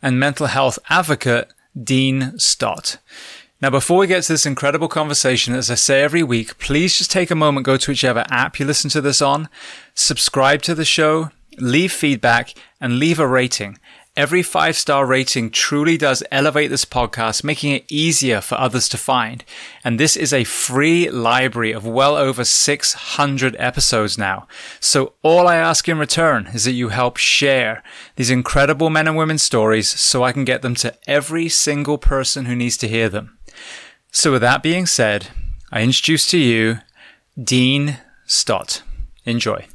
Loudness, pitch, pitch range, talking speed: -16 LUFS, 135 Hz, 120-150 Hz, 170 wpm